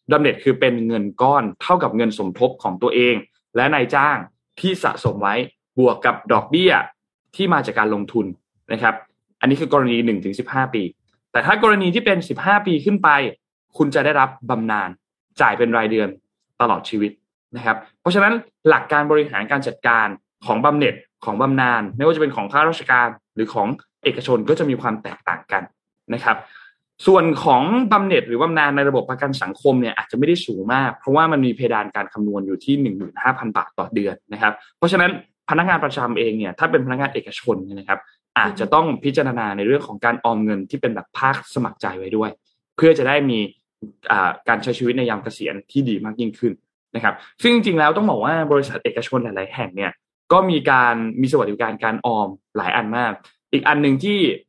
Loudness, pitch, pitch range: -19 LUFS, 125 Hz, 110-155 Hz